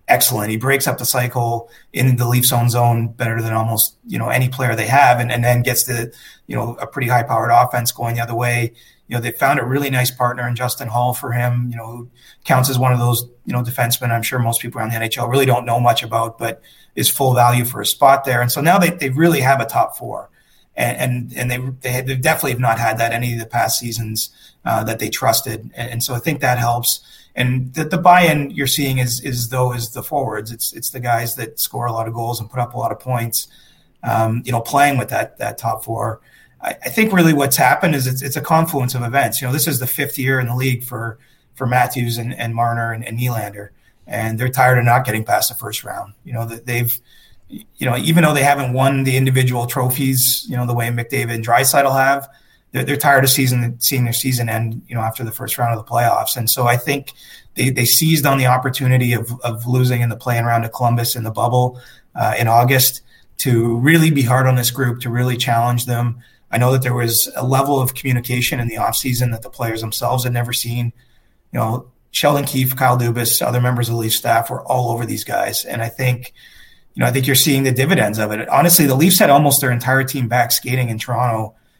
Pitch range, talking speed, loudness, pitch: 115-130 Hz, 245 wpm, -17 LUFS, 125 Hz